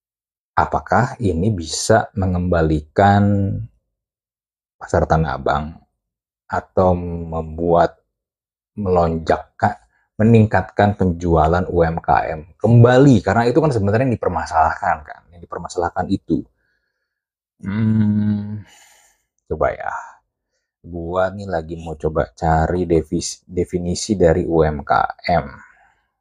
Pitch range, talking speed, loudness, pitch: 85-105 Hz, 80 wpm, -18 LUFS, 90 Hz